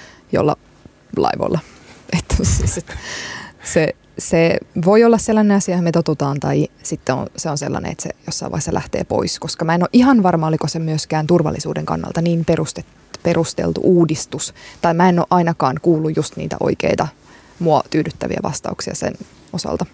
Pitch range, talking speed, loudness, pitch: 155-180 Hz, 165 wpm, -18 LUFS, 170 Hz